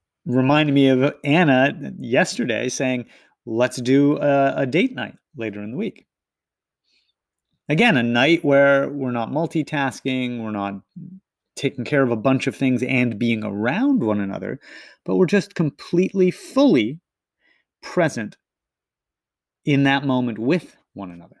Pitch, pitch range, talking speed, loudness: 135 Hz, 120-150 Hz, 135 wpm, -20 LUFS